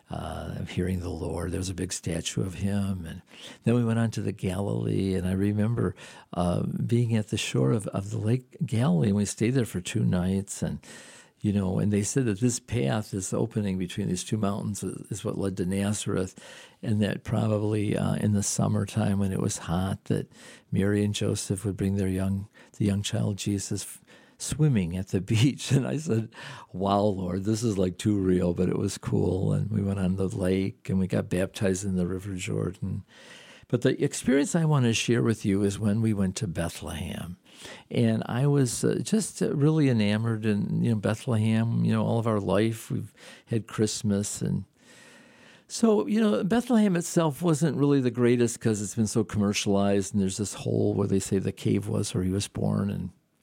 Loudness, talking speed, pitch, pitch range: -27 LUFS, 200 wpm, 105 Hz, 95-115 Hz